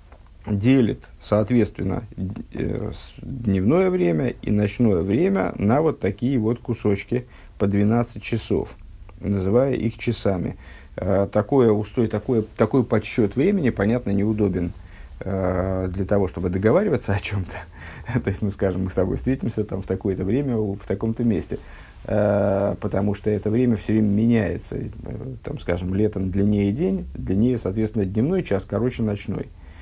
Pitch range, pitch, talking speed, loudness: 95-115 Hz, 105 Hz, 130 wpm, -22 LUFS